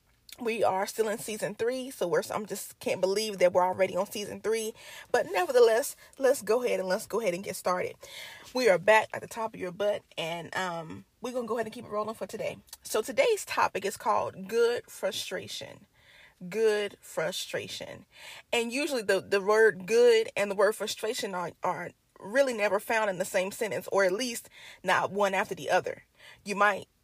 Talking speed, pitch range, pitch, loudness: 195 wpm, 200-255 Hz, 215 Hz, -29 LUFS